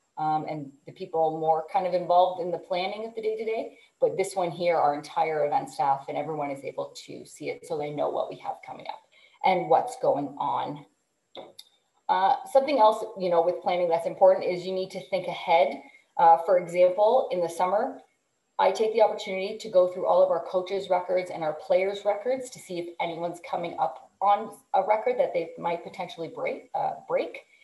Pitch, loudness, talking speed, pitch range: 185 Hz, -26 LUFS, 210 wpm, 170-215 Hz